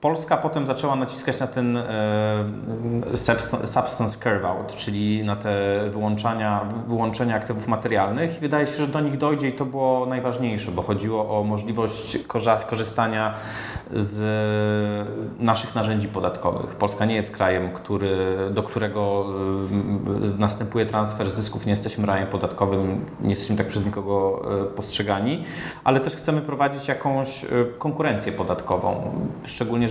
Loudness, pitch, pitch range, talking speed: -24 LUFS, 110 Hz, 105-120 Hz, 130 wpm